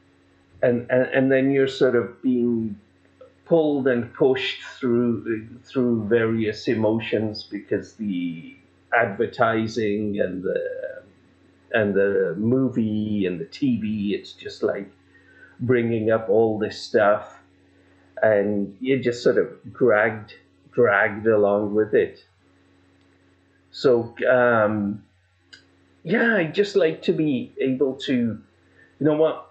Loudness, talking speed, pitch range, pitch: -22 LUFS, 115 wpm, 95-130 Hz, 110 Hz